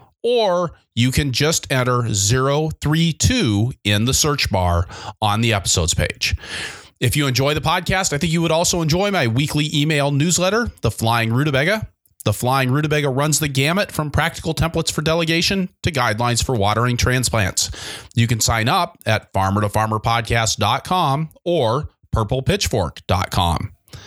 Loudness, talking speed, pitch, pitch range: -18 LUFS, 145 wpm, 130 Hz, 115-155 Hz